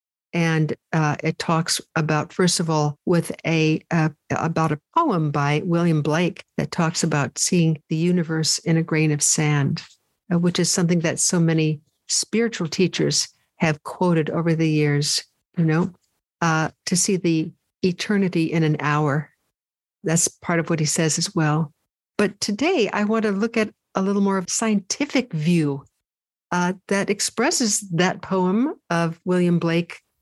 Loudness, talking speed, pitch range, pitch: -21 LUFS, 165 wpm, 155-185 Hz, 165 Hz